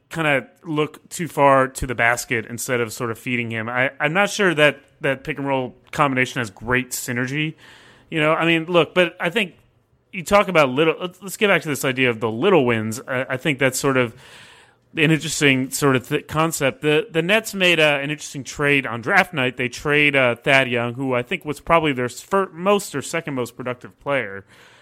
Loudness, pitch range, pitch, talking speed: -20 LUFS, 125-160 Hz, 140 Hz, 220 wpm